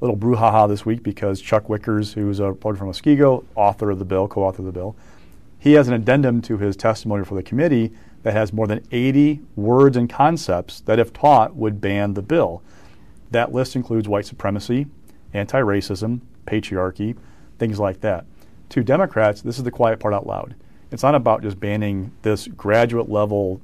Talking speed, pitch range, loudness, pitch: 190 wpm, 100-120 Hz, -20 LUFS, 110 Hz